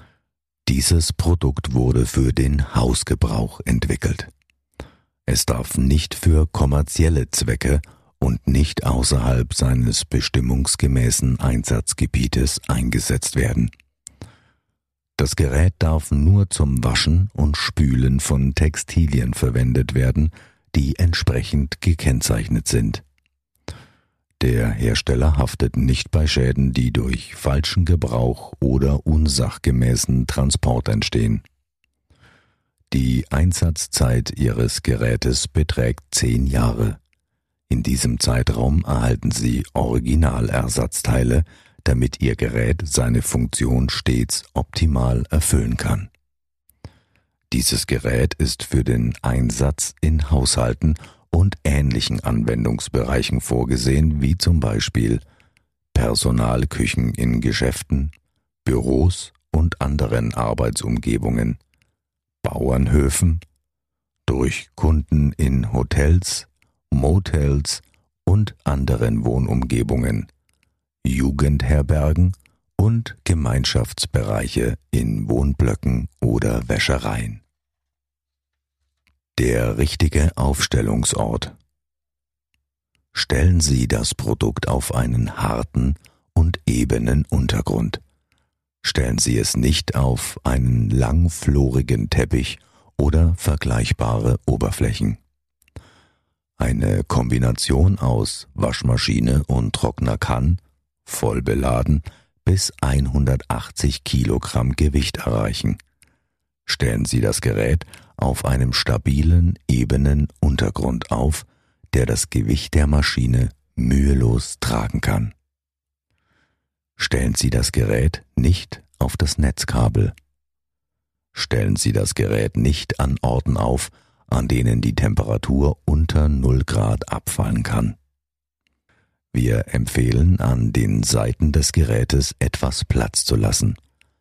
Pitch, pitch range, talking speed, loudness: 70 Hz, 65-85 Hz, 90 wpm, -20 LUFS